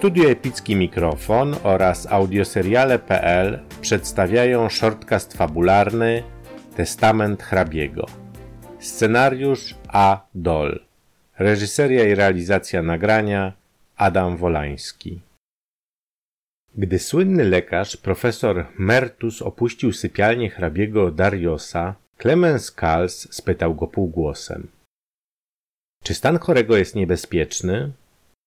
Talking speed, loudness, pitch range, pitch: 80 wpm, -20 LUFS, 90-115 Hz, 100 Hz